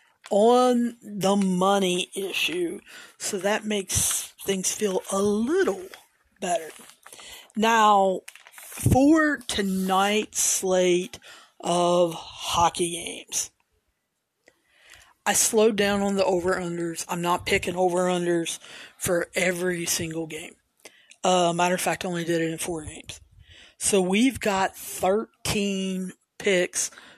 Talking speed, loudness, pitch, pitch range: 115 wpm, -24 LUFS, 190 Hz, 175-205 Hz